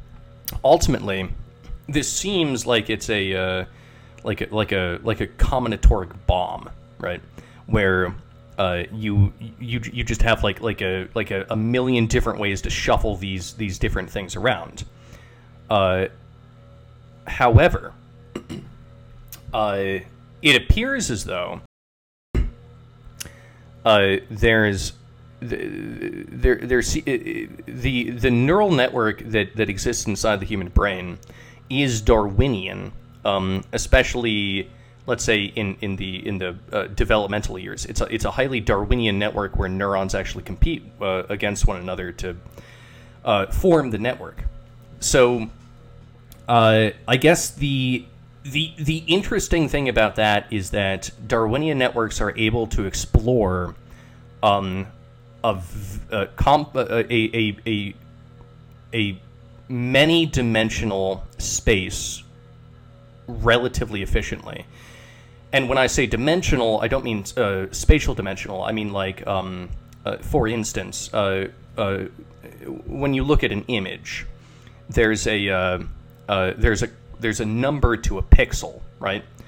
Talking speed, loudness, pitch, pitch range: 125 wpm, -22 LUFS, 115 Hz, 100-120 Hz